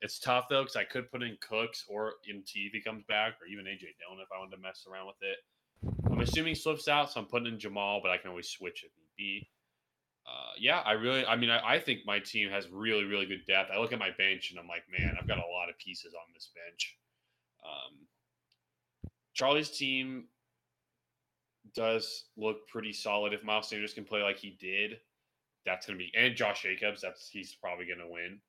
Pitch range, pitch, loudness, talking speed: 95-115 Hz, 105 Hz, -33 LUFS, 225 wpm